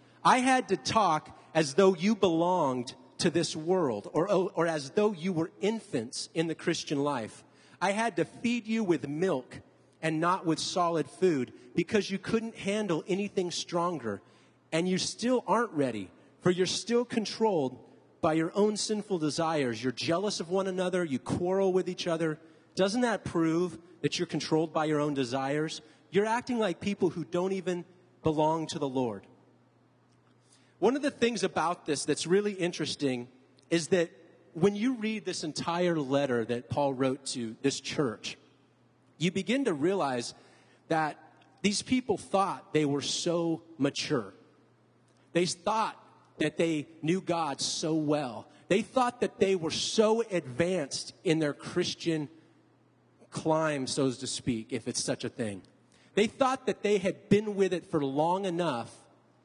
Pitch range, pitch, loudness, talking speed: 140-190 Hz, 165 Hz, -30 LUFS, 160 wpm